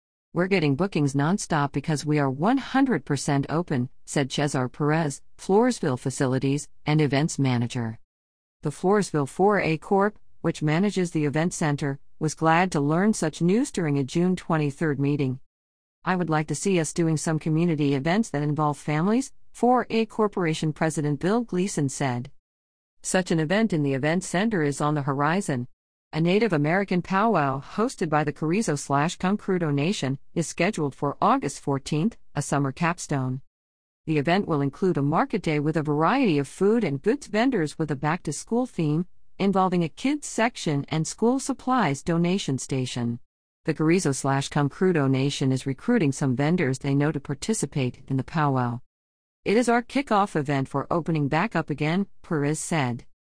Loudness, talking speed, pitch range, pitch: -25 LUFS, 160 wpm, 140-185 Hz, 155 Hz